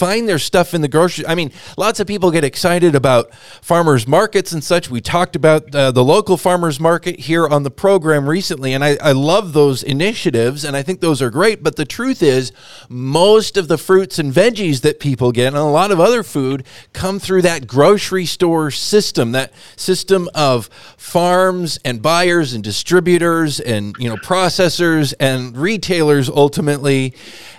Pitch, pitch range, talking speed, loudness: 160 Hz, 140-180 Hz, 180 wpm, -14 LUFS